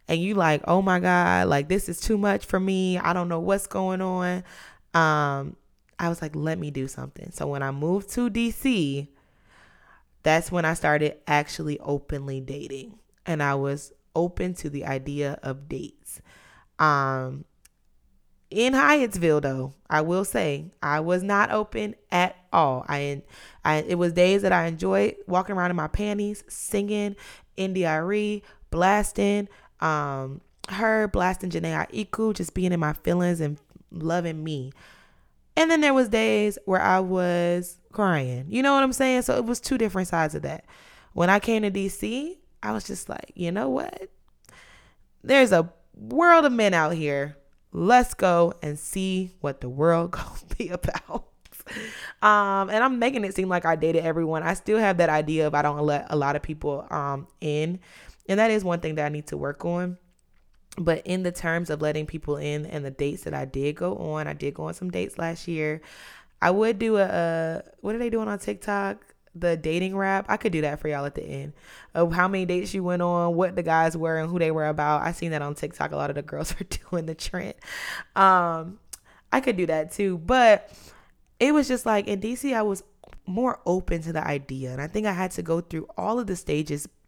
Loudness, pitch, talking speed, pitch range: -25 LUFS, 175 Hz, 200 wpm, 150-200 Hz